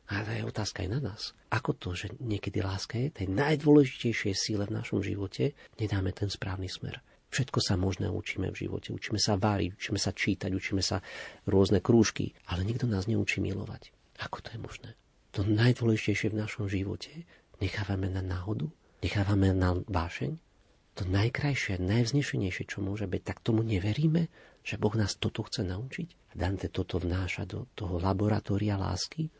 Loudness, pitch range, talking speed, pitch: -31 LUFS, 95-115 Hz, 165 wpm, 105 Hz